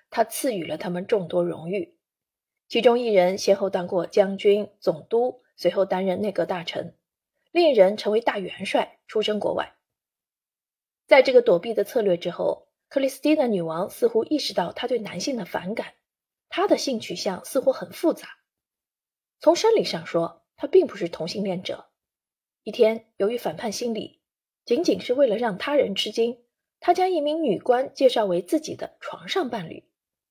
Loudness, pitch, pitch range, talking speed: -24 LUFS, 225 Hz, 190-285 Hz, 255 characters per minute